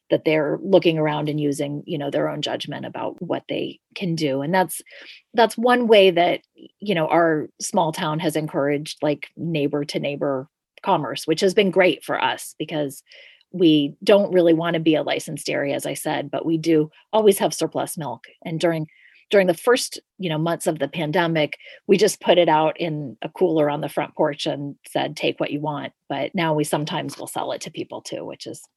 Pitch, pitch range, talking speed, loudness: 160 Hz, 150-185 Hz, 210 wpm, -21 LUFS